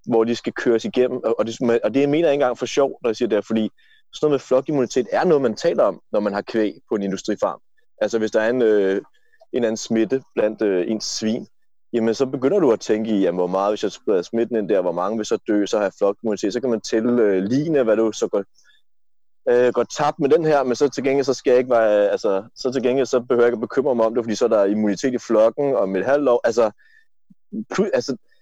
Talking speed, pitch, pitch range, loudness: 275 wpm, 120 Hz, 110-140 Hz, -20 LUFS